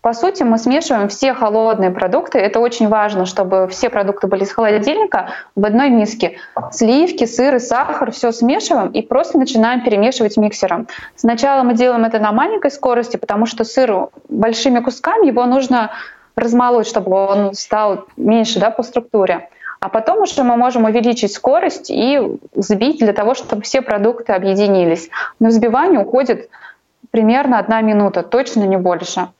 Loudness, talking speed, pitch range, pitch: -15 LUFS, 155 wpm, 205-250 Hz, 230 Hz